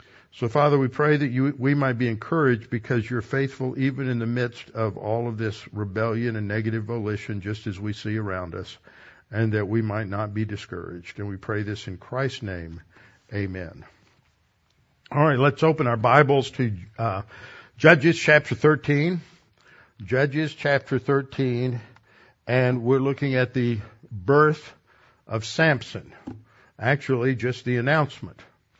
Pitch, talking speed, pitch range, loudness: 120 Hz, 150 wpm, 105-135 Hz, -24 LUFS